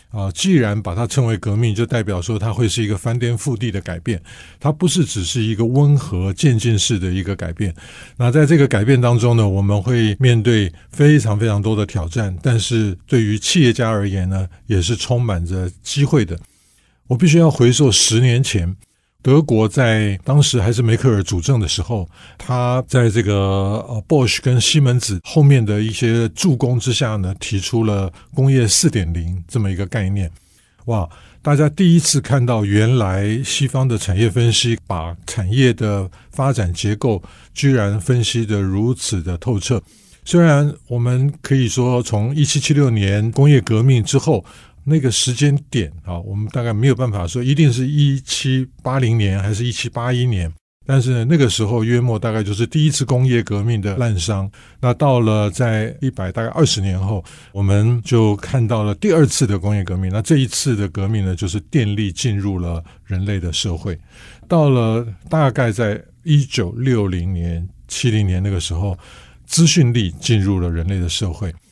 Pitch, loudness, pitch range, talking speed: 115 Hz, -17 LUFS, 100-130 Hz, 265 characters per minute